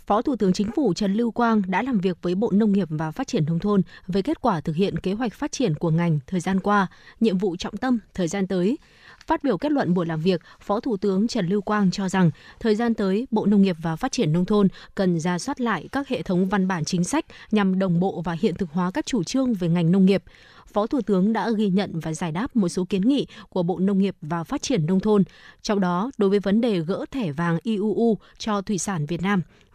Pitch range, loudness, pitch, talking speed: 180-225 Hz, -23 LUFS, 200 Hz, 260 wpm